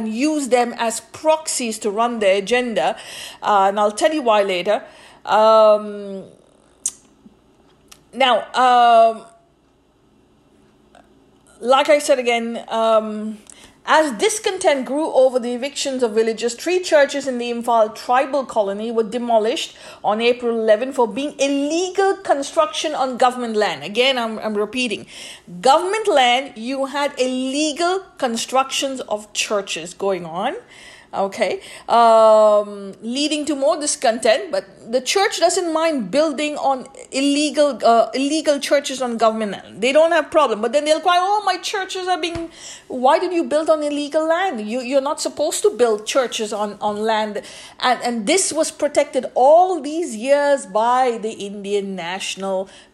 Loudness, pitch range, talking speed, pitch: -18 LUFS, 220-300 Hz, 140 wpm, 255 Hz